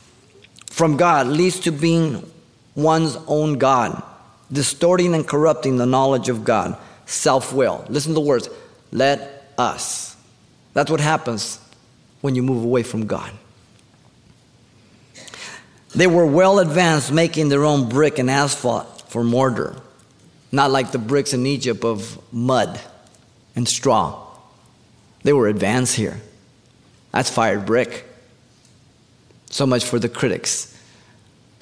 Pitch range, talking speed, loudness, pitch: 120-145 Hz, 125 wpm, -19 LUFS, 125 Hz